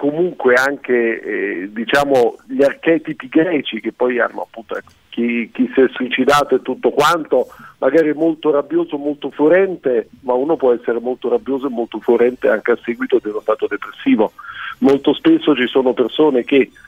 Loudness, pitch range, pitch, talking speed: -16 LUFS, 125-165 Hz, 140 Hz, 165 wpm